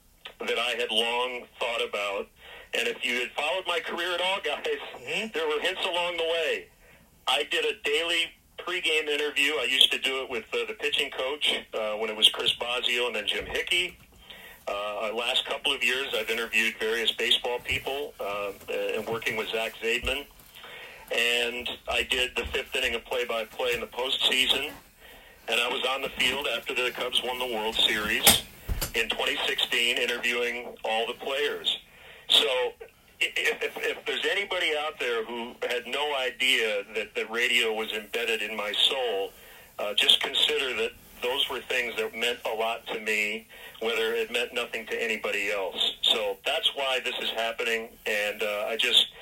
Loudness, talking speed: -26 LUFS, 175 wpm